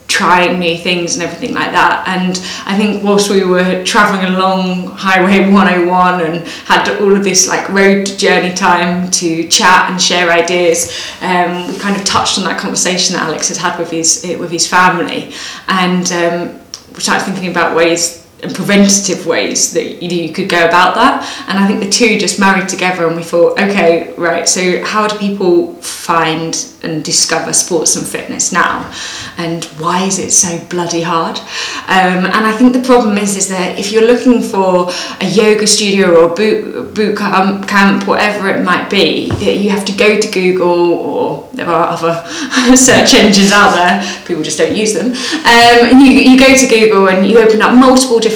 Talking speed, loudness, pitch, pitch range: 185 wpm, -10 LUFS, 185 Hz, 175-210 Hz